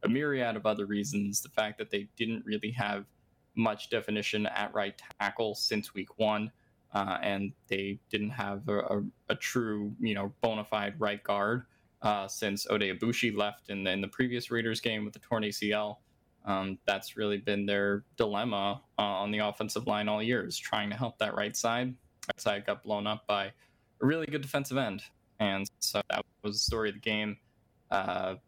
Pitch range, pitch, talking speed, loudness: 100-115 Hz, 105 Hz, 190 wpm, -33 LUFS